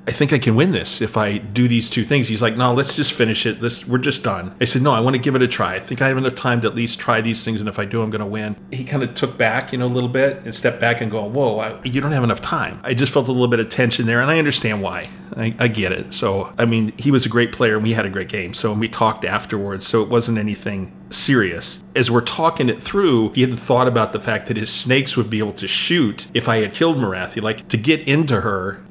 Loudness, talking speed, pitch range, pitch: -18 LUFS, 300 wpm, 110-130 Hz, 115 Hz